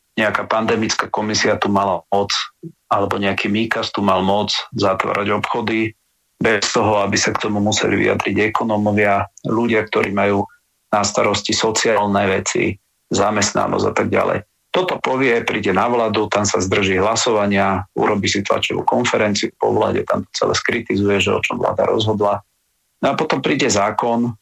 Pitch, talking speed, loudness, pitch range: 105 Hz, 155 wpm, -18 LUFS, 100-110 Hz